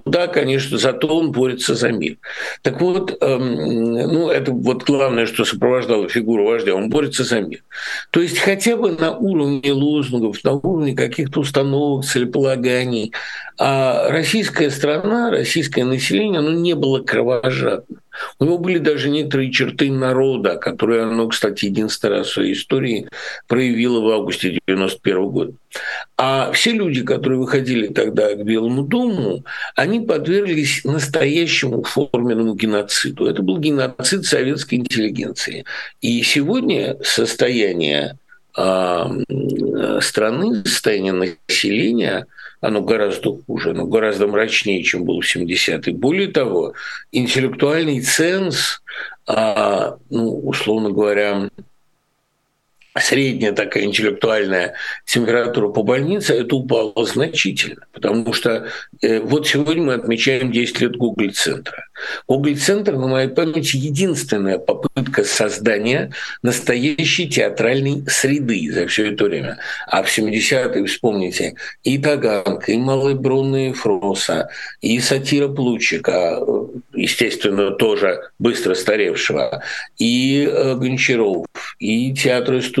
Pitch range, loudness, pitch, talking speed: 120-155 Hz, -18 LUFS, 135 Hz, 120 wpm